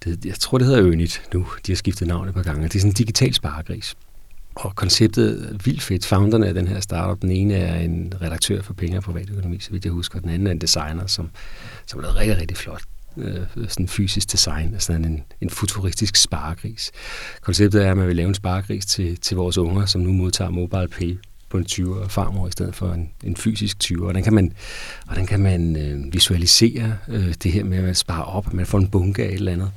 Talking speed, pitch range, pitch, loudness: 240 wpm, 90-105 Hz, 95 Hz, -21 LUFS